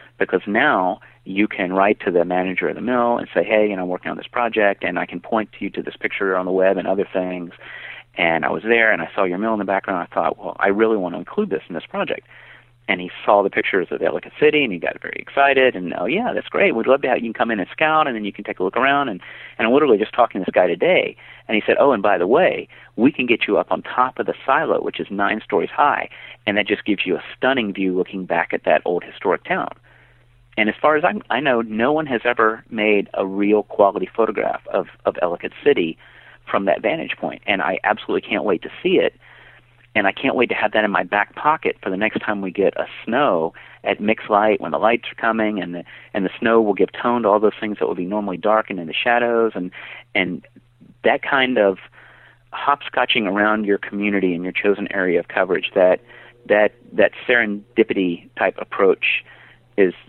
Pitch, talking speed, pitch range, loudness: 105 Hz, 245 wpm, 95-120 Hz, -19 LUFS